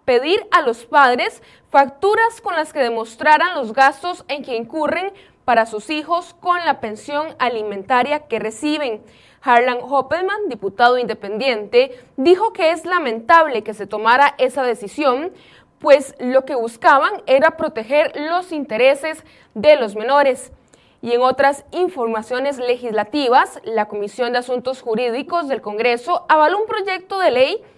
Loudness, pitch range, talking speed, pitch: -17 LUFS, 240-330 Hz, 140 wpm, 275 Hz